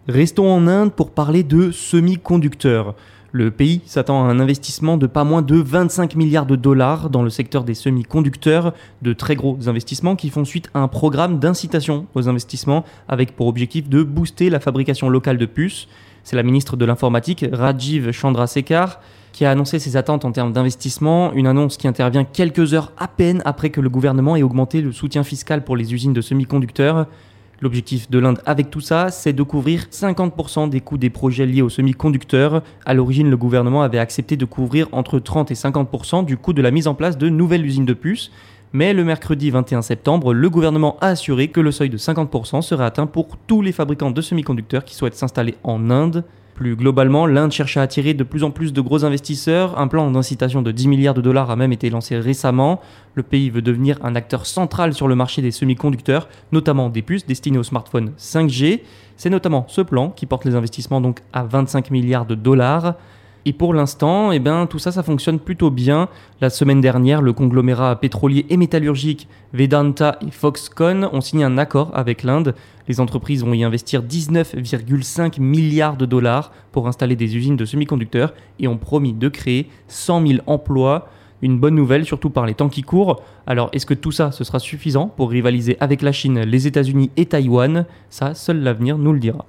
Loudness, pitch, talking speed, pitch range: -17 LUFS, 140 Hz, 200 wpm, 125-155 Hz